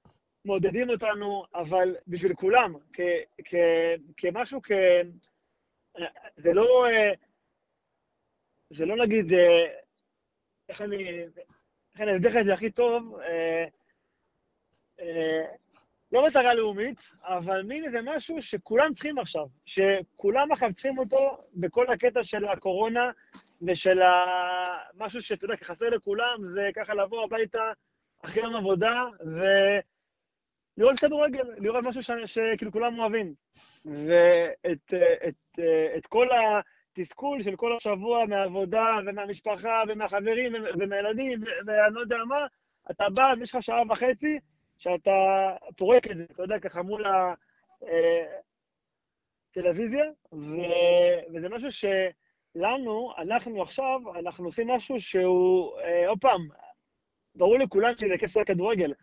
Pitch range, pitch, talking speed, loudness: 180-245 Hz, 215 Hz, 115 wpm, -26 LUFS